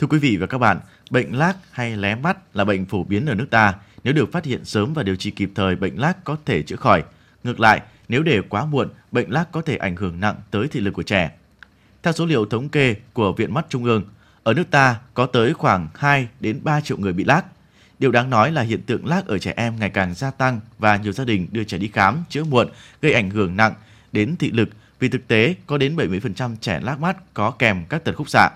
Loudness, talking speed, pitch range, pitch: -20 LUFS, 255 wpm, 105-140 Hz, 115 Hz